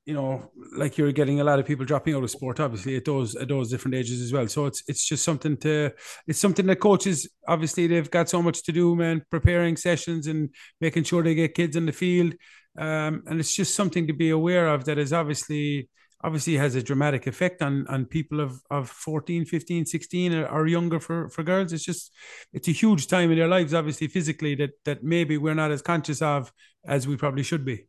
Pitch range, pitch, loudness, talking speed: 145-170 Hz, 155 Hz, -25 LUFS, 230 wpm